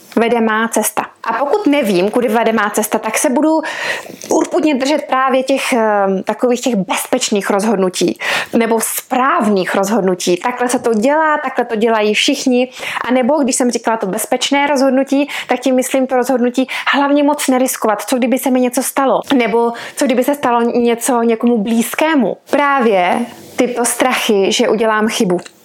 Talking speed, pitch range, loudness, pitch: 160 wpm, 225-270 Hz, -14 LUFS, 250 Hz